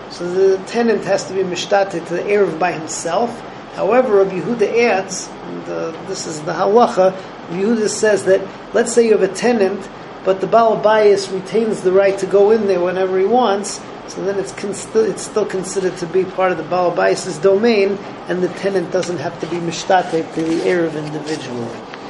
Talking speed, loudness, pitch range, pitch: 200 wpm, -17 LUFS, 175-200 Hz, 190 Hz